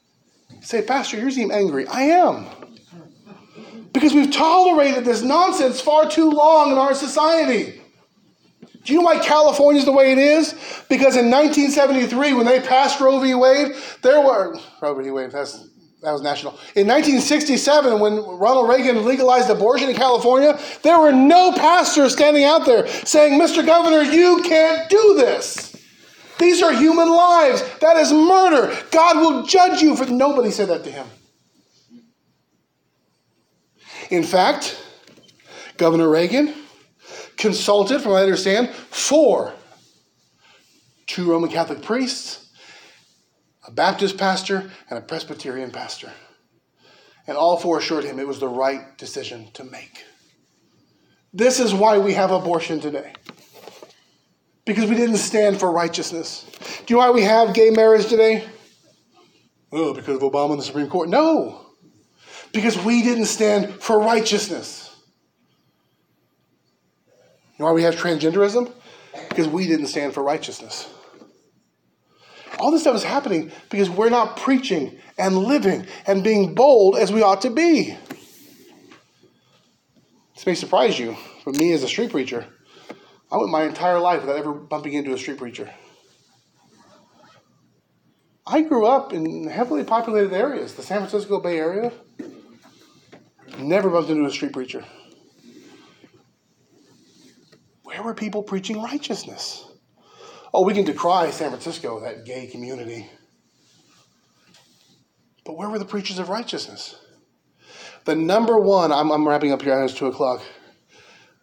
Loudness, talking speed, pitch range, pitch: -17 LUFS, 140 wpm, 170-285 Hz, 225 Hz